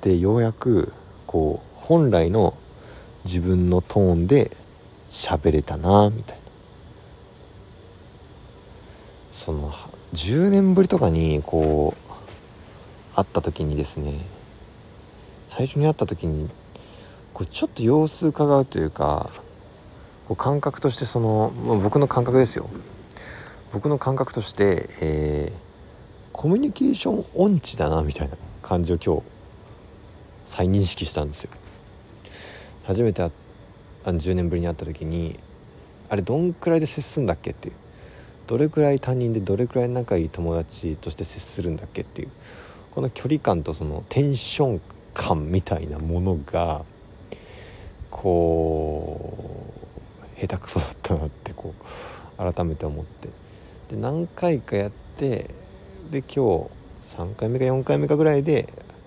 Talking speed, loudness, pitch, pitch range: 255 characters per minute, -23 LUFS, 95 Hz, 85-120 Hz